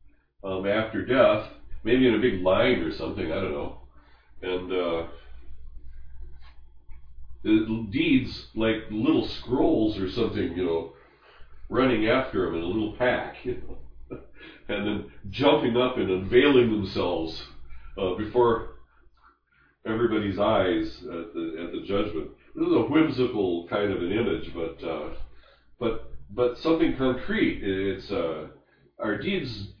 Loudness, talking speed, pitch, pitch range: -26 LUFS, 140 wpm, 100 Hz, 75-120 Hz